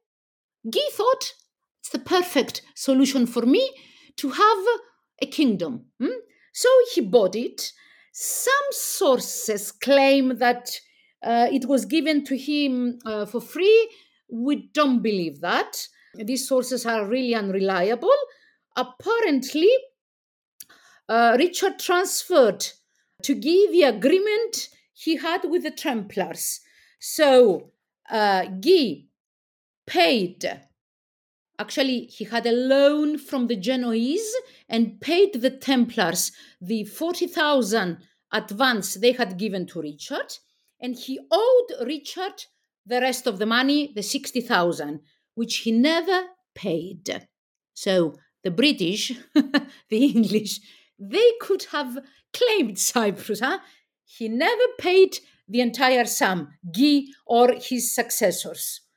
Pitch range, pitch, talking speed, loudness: 225-340 Hz, 260 Hz, 115 wpm, -22 LUFS